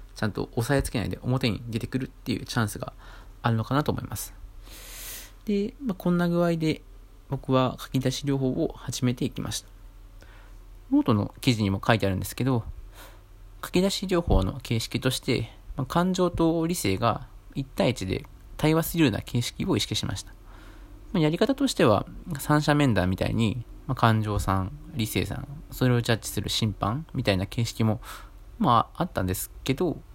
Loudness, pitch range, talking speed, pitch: -27 LUFS, 100-140 Hz, 345 characters per minute, 120 Hz